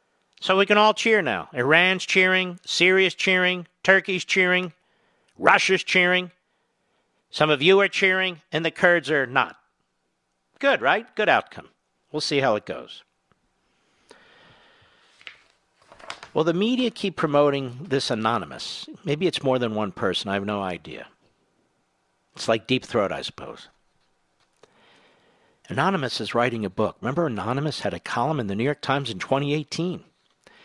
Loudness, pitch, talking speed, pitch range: -22 LUFS, 155 Hz, 145 wpm, 125-185 Hz